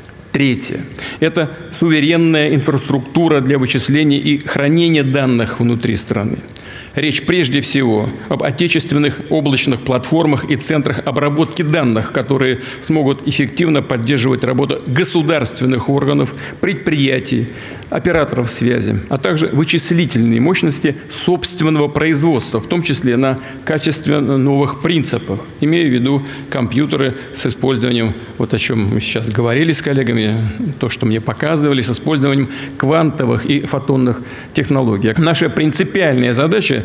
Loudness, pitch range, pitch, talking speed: -15 LUFS, 125-155 Hz, 140 Hz, 115 wpm